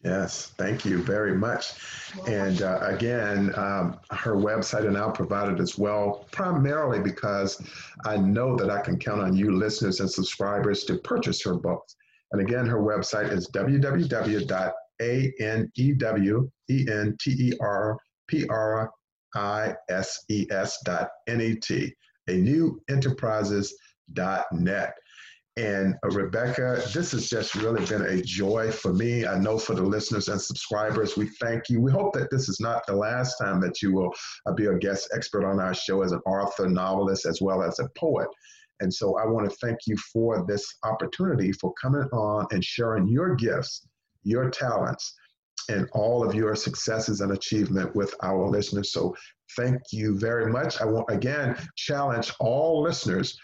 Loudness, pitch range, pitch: -27 LUFS, 100-125 Hz, 110 Hz